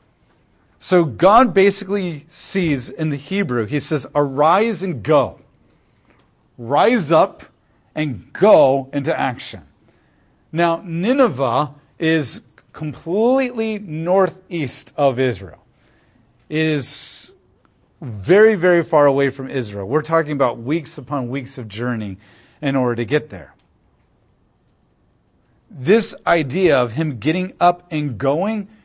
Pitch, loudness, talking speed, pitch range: 150 Hz, -18 LUFS, 110 wpm, 135-180 Hz